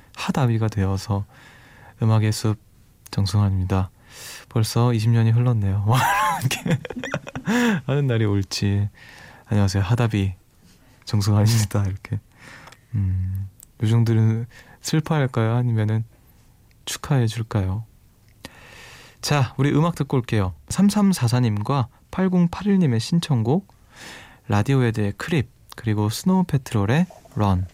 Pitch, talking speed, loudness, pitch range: 115 Hz, 235 characters per minute, -22 LUFS, 105-135 Hz